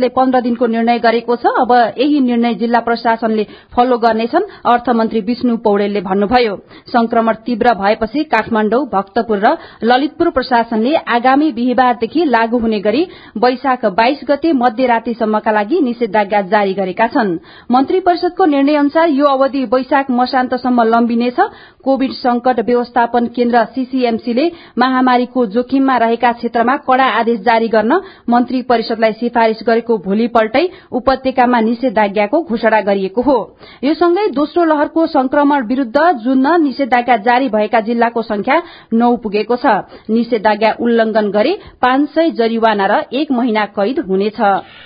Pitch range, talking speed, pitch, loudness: 225-270 Hz, 130 wpm, 245 Hz, -14 LUFS